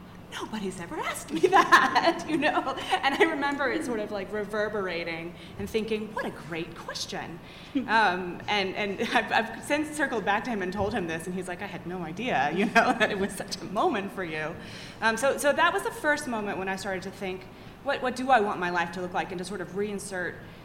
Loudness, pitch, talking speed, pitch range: -27 LUFS, 210 Hz, 230 wpm, 185-255 Hz